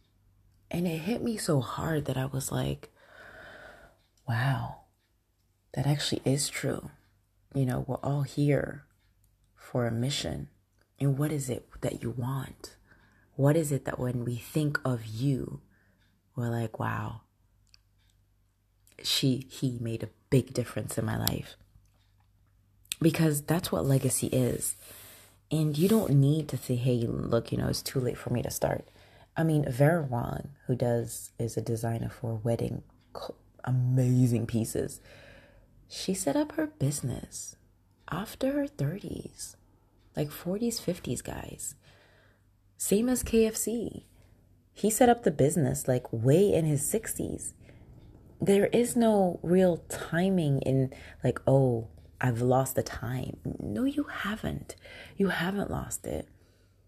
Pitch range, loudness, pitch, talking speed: 100-145 Hz, -30 LUFS, 125 Hz, 140 wpm